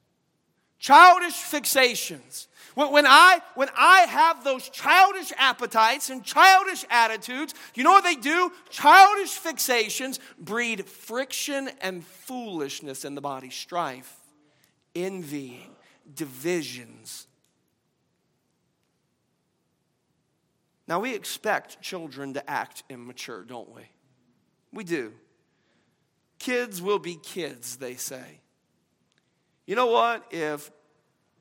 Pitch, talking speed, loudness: 235 Hz, 95 wpm, -20 LUFS